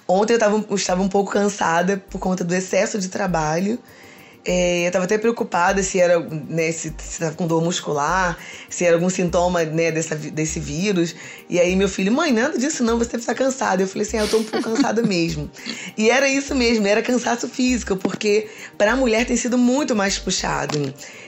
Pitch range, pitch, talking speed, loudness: 175-225 Hz, 195 Hz, 205 wpm, -20 LUFS